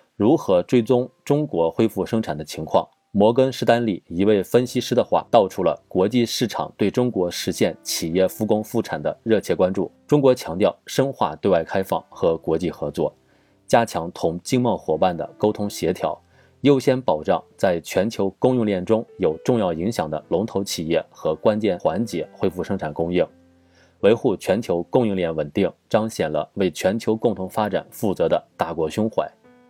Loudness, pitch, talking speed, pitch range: -22 LUFS, 110 Hz, 270 characters per minute, 95-125 Hz